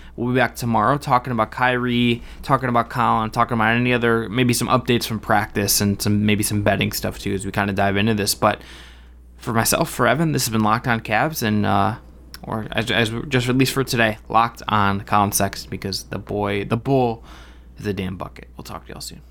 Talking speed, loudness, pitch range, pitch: 220 wpm, -20 LUFS, 100-120 Hz, 110 Hz